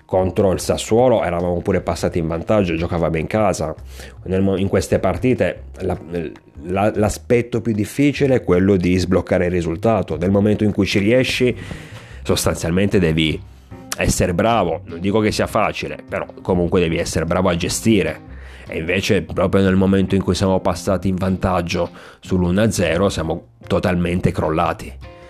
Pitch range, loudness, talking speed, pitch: 85-105 Hz, -18 LUFS, 140 wpm, 95 Hz